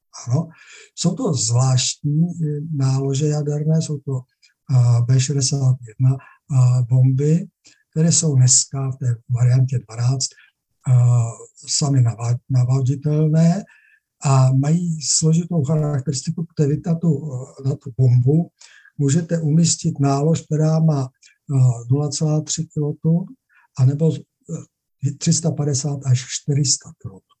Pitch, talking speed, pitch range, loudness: 145 Hz, 90 wpm, 130-160 Hz, -19 LUFS